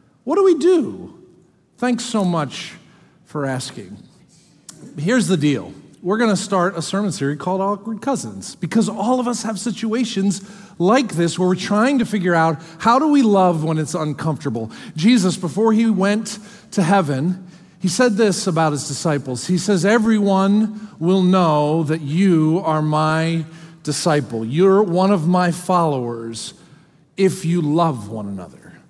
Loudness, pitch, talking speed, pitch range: -18 LUFS, 180 Hz, 155 wpm, 160-205 Hz